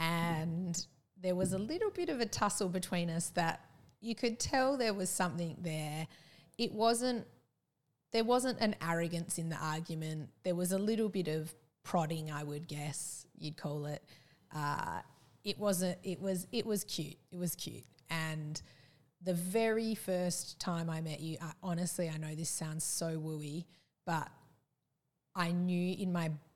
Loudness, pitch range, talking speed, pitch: -37 LUFS, 155-190 Hz, 165 wpm, 170 Hz